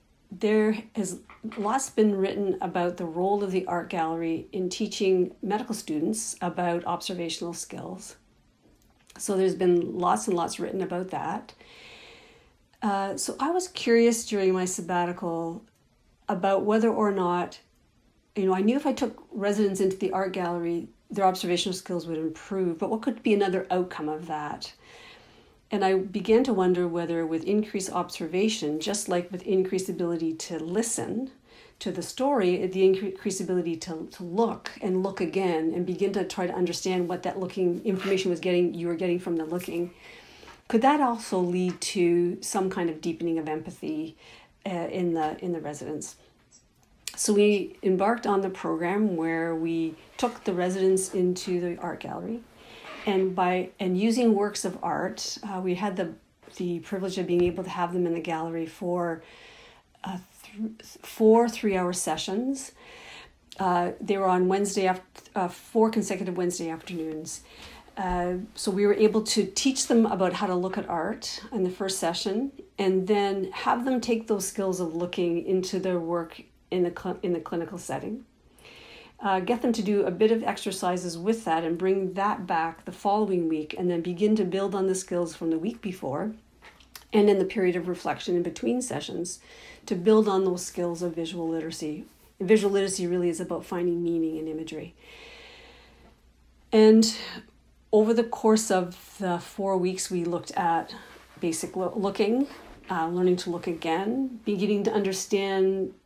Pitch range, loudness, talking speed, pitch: 175-210 Hz, -27 LUFS, 170 wpm, 185 Hz